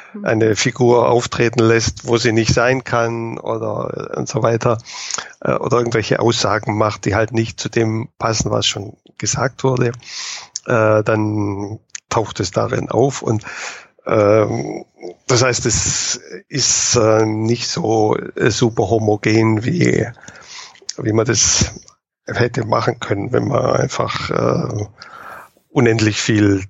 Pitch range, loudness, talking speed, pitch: 110-120 Hz, -17 LUFS, 120 wpm, 115 Hz